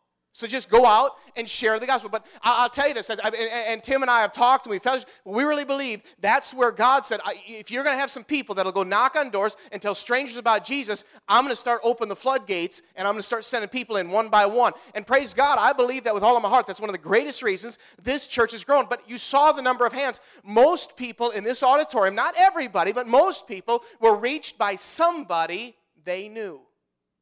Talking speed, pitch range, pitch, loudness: 235 wpm, 215-265 Hz, 240 Hz, -22 LUFS